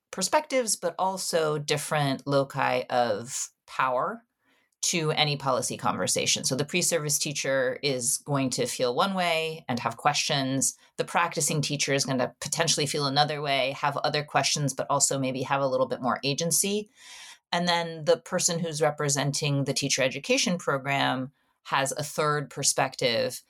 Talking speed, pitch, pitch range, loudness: 155 wpm, 150 Hz, 140-170 Hz, -26 LUFS